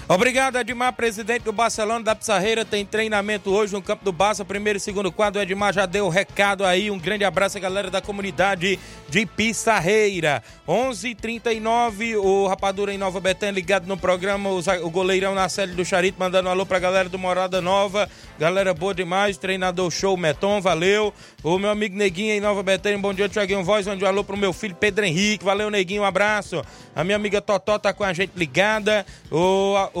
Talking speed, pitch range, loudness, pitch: 205 wpm, 190-210 Hz, -21 LUFS, 200 Hz